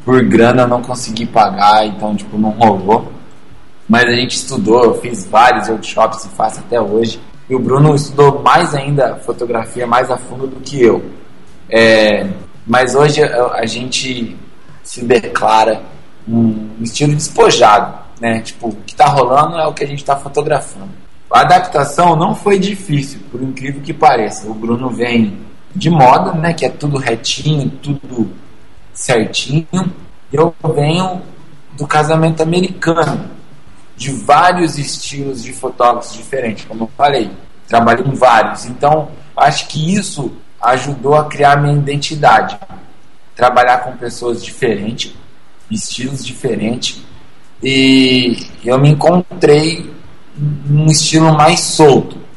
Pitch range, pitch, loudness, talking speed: 120-150 Hz, 135 Hz, -12 LUFS, 135 wpm